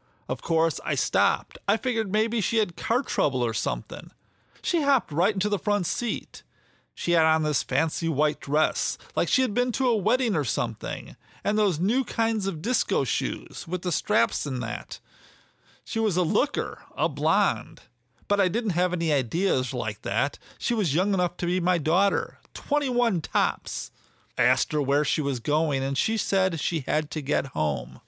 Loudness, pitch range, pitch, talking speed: -26 LUFS, 155-225 Hz, 180 Hz, 185 wpm